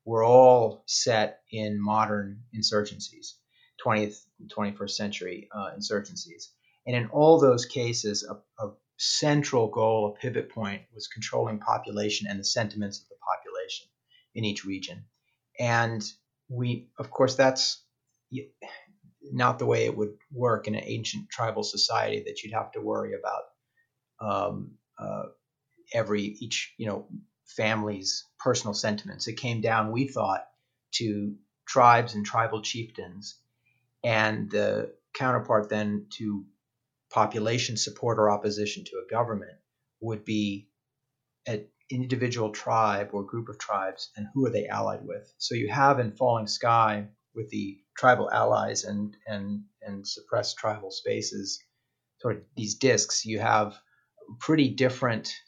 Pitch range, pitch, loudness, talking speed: 105-130 Hz, 110 Hz, -27 LUFS, 135 wpm